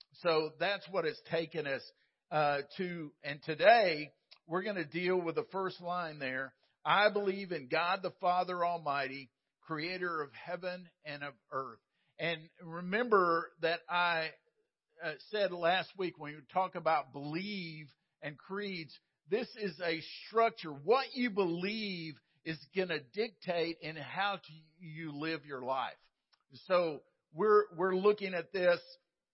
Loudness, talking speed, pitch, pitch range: -35 LUFS, 145 wpm, 170 Hz, 155-190 Hz